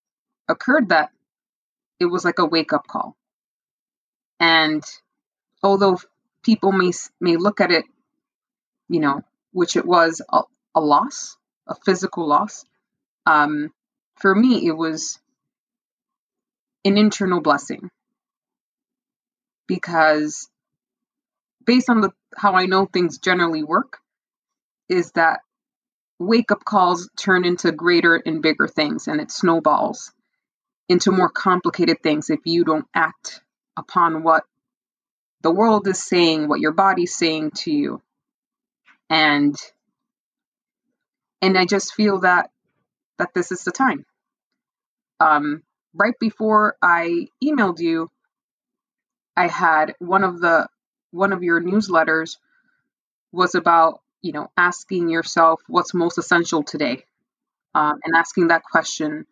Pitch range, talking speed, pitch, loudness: 165-220 Hz, 120 wpm, 180 Hz, -19 LUFS